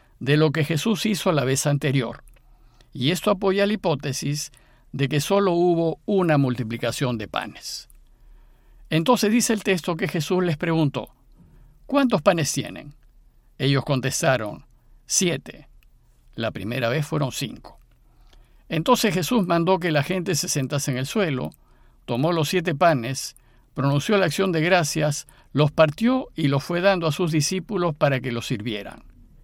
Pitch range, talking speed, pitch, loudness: 135-185 Hz, 150 wpm, 155 Hz, -23 LUFS